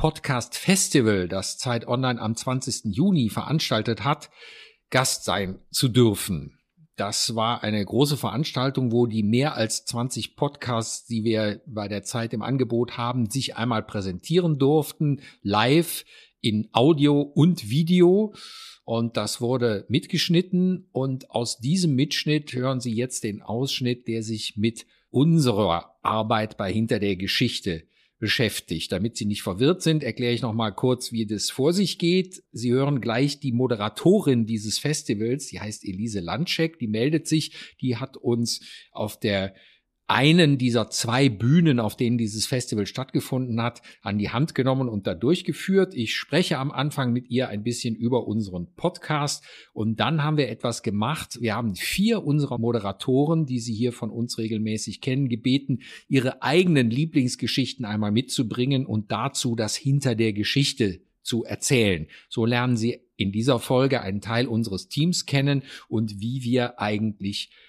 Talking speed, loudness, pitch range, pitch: 155 wpm, -24 LUFS, 110-145 Hz, 125 Hz